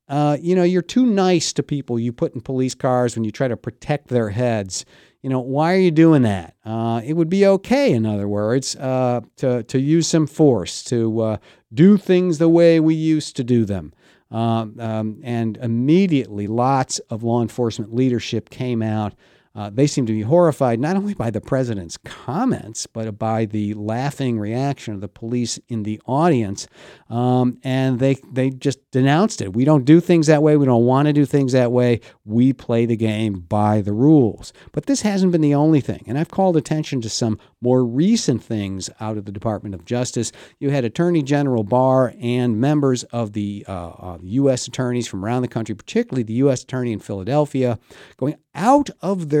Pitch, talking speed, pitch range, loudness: 125 Hz, 200 wpm, 115-150 Hz, -19 LUFS